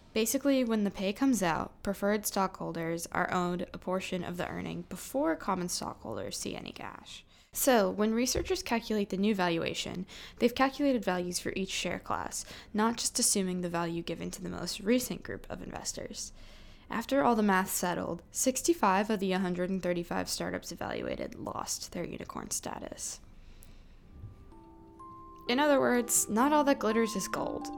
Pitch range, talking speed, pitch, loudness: 180-245 Hz, 155 wpm, 205 Hz, -31 LUFS